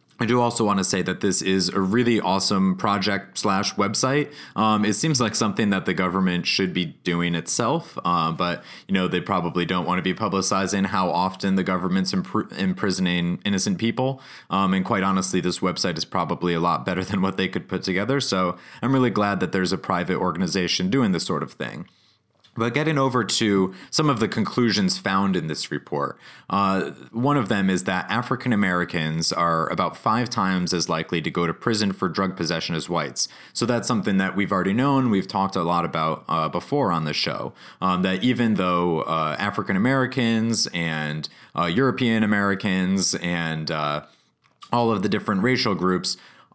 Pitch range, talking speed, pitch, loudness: 90-115 Hz, 190 wpm, 95 Hz, -23 LUFS